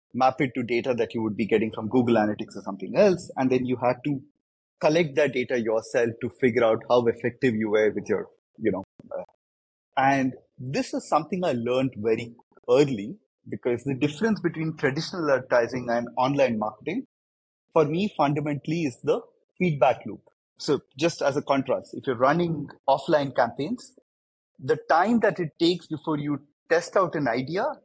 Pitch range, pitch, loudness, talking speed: 115-160 Hz, 135 Hz, -25 LUFS, 170 wpm